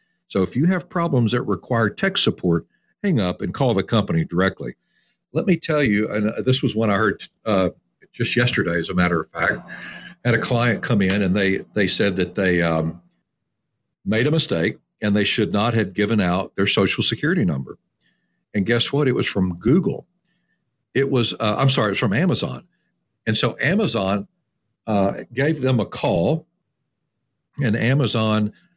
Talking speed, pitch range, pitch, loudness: 180 wpm, 100-135 Hz, 110 Hz, -20 LUFS